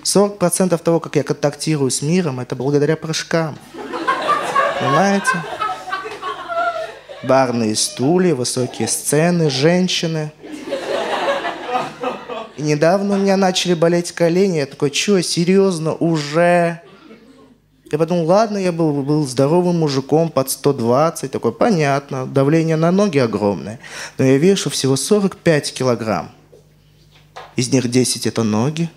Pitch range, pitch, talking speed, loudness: 140-180 Hz, 160 Hz, 115 wpm, -17 LUFS